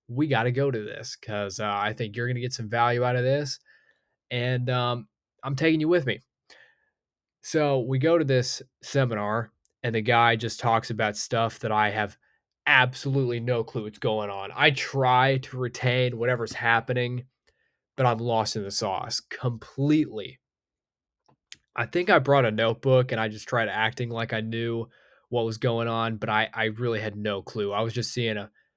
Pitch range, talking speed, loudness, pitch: 110-130 Hz, 190 wpm, -26 LUFS, 120 Hz